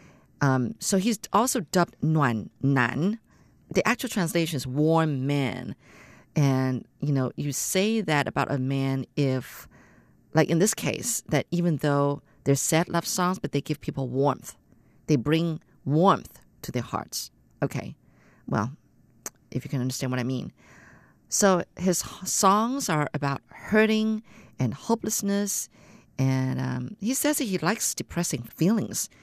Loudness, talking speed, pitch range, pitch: -26 LUFS, 145 wpm, 135-190 Hz, 150 Hz